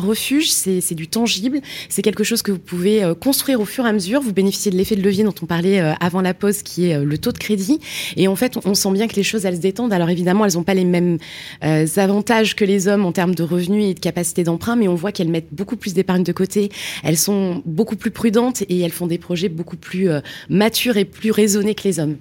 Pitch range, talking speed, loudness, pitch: 175-215 Hz, 275 wpm, -18 LUFS, 195 Hz